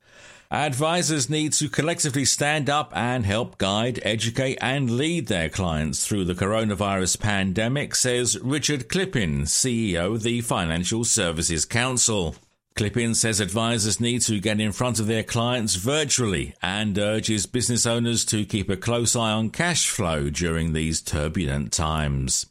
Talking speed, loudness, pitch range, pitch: 145 wpm, -23 LUFS, 95-125 Hz, 110 Hz